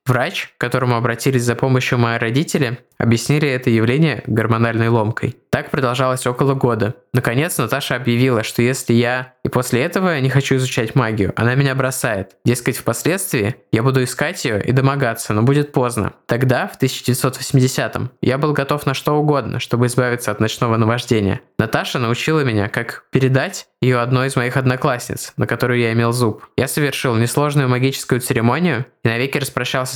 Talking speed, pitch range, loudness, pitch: 160 wpm, 115-135 Hz, -18 LUFS, 125 Hz